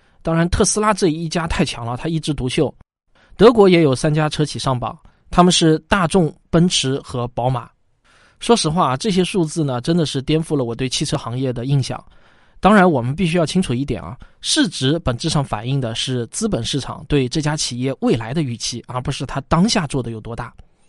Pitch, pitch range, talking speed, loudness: 150 Hz, 125-170 Hz, 300 characters per minute, -18 LUFS